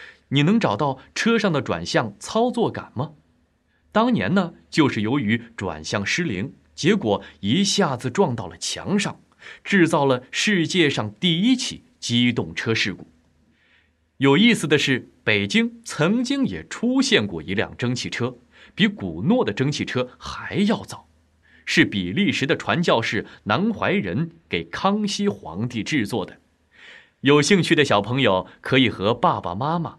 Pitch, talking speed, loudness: 140 Hz, 220 characters per minute, -21 LUFS